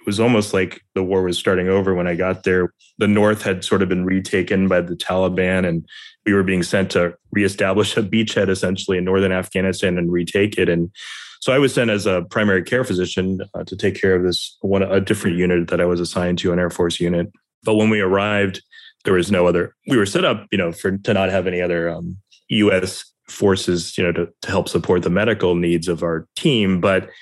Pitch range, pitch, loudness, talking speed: 90-95 Hz, 95 Hz, -19 LUFS, 230 wpm